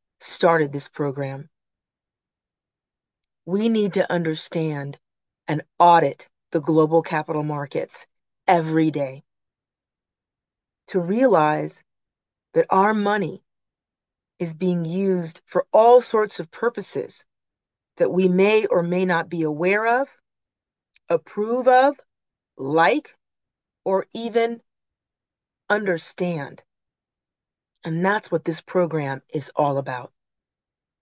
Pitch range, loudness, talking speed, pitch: 155-210 Hz, -21 LUFS, 100 wpm, 175 Hz